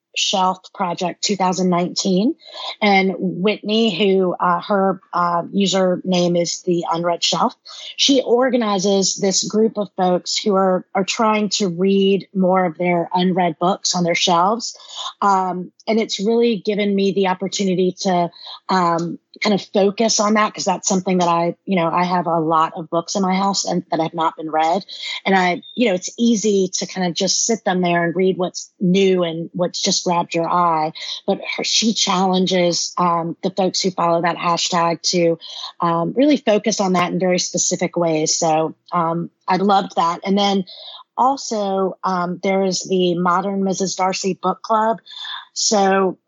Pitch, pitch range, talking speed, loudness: 185 Hz, 175-200 Hz, 170 wpm, -18 LUFS